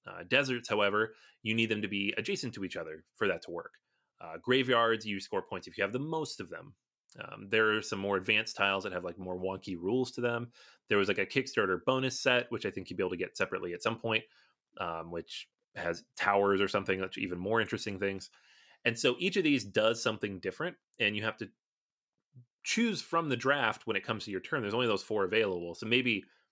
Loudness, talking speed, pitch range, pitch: -32 LUFS, 230 wpm, 100-125 Hz, 110 Hz